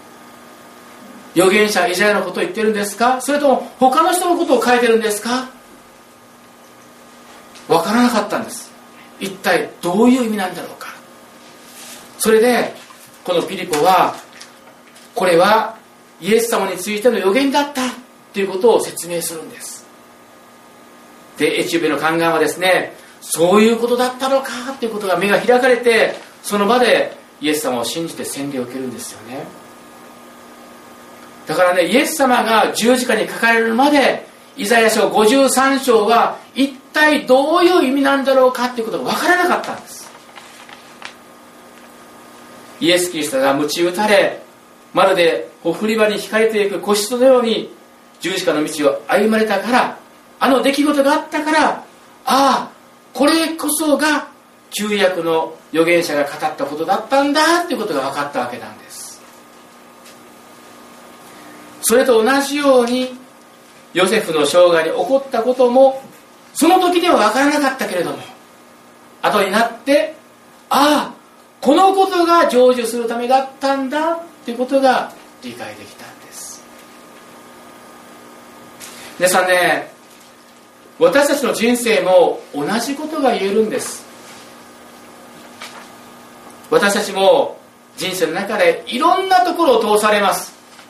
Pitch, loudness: 220 Hz, -15 LUFS